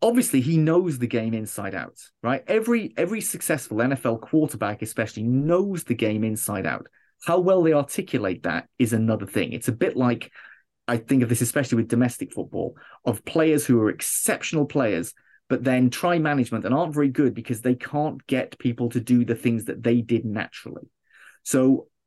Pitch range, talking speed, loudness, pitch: 115-150 Hz, 180 wpm, -24 LUFS, 125 Hz